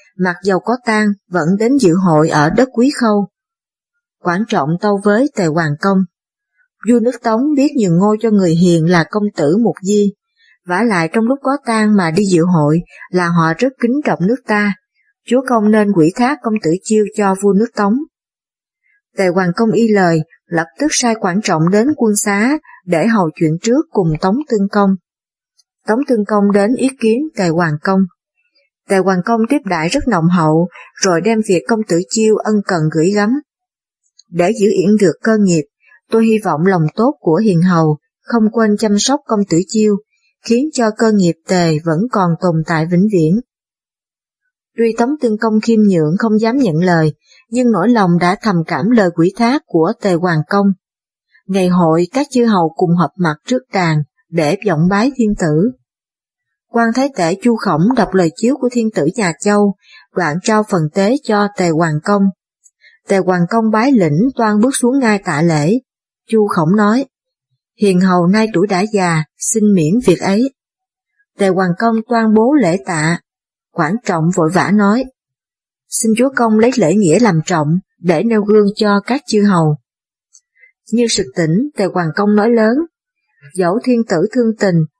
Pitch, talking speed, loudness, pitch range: 205 Hz, 185 wpm, -14 LUFS, 175-230 Hz